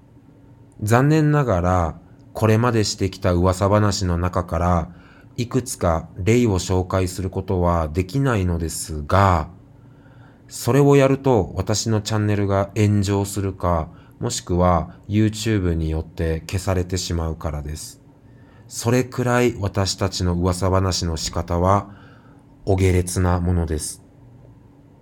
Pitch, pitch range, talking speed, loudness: 100 Hz, 90-125 Hz, 260 characters per minute, -21 LUFS